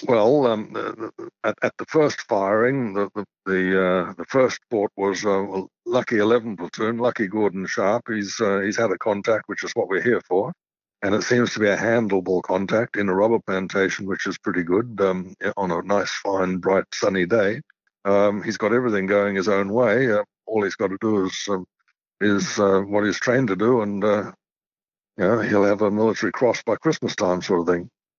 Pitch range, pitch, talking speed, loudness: 95-115 Hz, 100 Hz, 210 wpm, -22 LUFS